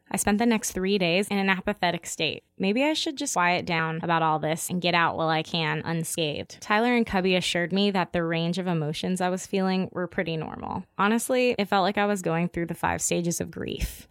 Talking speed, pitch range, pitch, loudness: 235 wpm, 165-200 Hz, 180 Hz, -26 LUFS